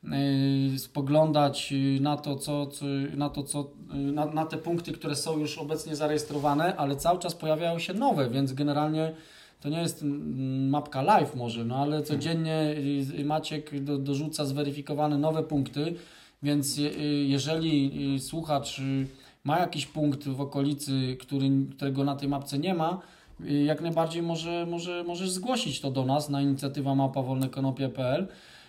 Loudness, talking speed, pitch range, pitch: -29 LUFS, 140 wpm, 140-155 Hz, 145 Hz